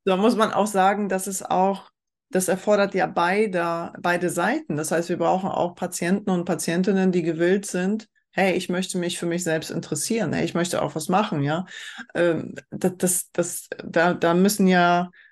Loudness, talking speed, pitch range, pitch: -23 LUFS, 185 wpm, 170-195 Hz, 180 Hz